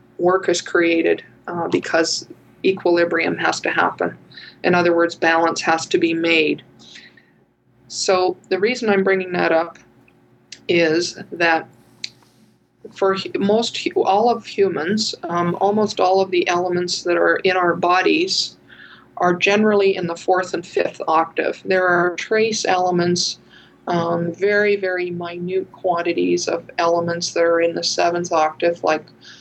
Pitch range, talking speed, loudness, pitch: 170-195 Hz, 140 wpm, -19 LUFS, 180 Hz